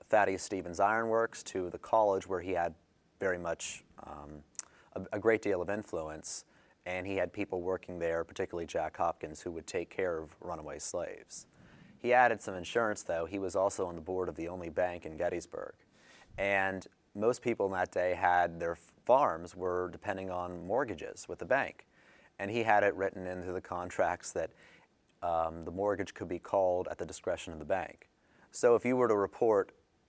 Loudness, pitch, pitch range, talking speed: -34 LUFS, 90 Hz, 85-100 Hz, 185 wpm